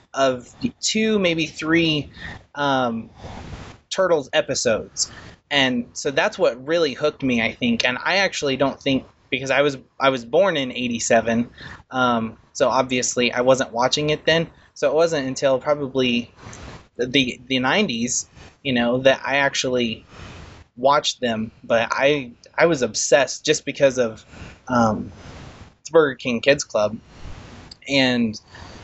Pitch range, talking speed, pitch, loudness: 115-140 Hz, 135 wpm, 130 Hz, -20 LUFS